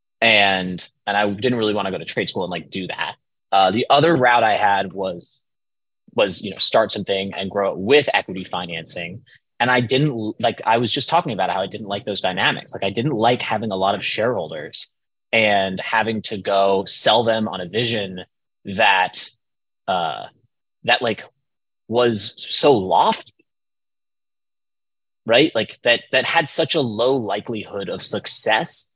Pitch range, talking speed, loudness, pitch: 95-115 Hz, 175 wpm, -19 LUFS, 105 Hz